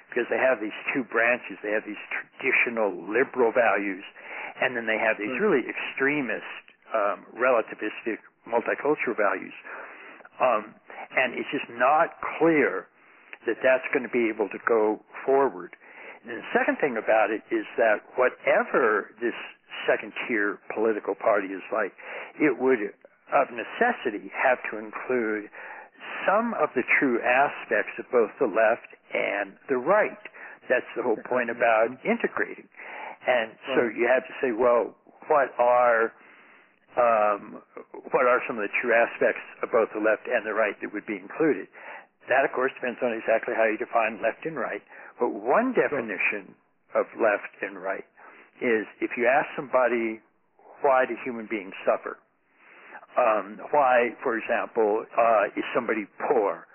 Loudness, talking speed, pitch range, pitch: -25 LUFS, 150 wpm, 110-130 Hz, 115 Hz